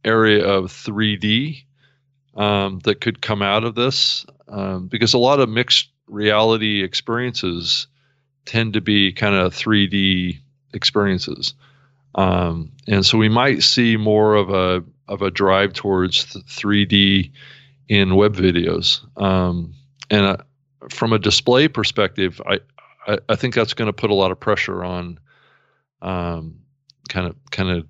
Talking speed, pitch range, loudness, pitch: 140 wpm, 95-125 Hz, -18 LUFS, 105 Hz